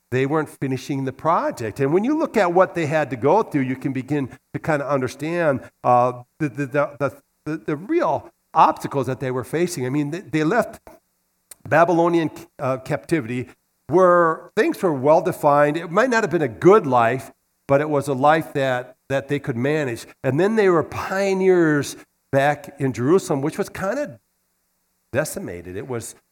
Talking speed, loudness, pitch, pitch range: 185 wpm, -21 LUFS, 150 Hz, 135-170 Hz